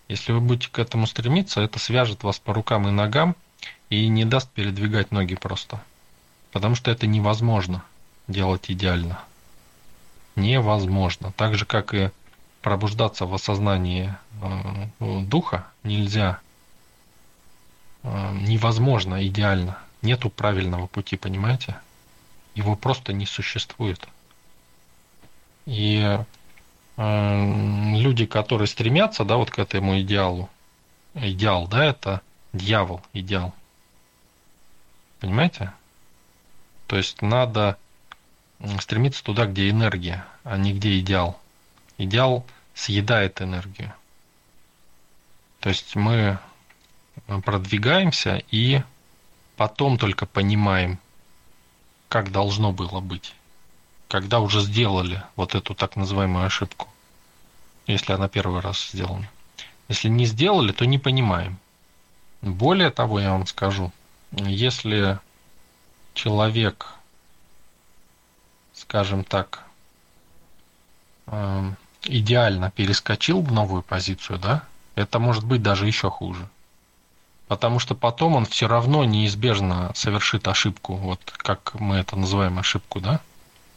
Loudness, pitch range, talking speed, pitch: -23 LUFS, 90-110 Hz, 100 wpm, 100 Hz